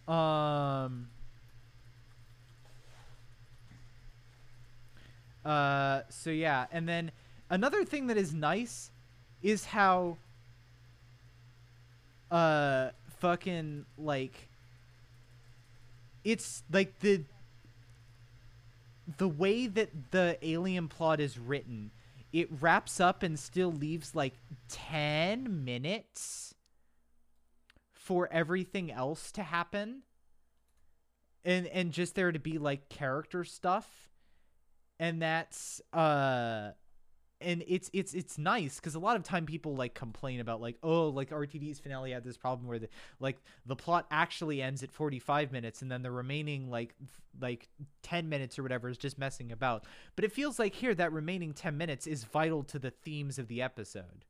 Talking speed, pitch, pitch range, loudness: 130 wpm, 135 Hz, 120-165 Hz, -34 LUFS